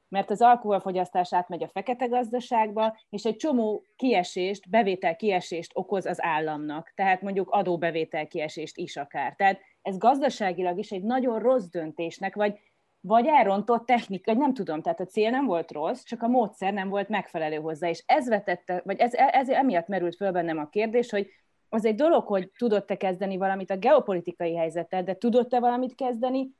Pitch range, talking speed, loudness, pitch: 180-235 Hz, 170 wpm, -26 LUFS, 195 Hz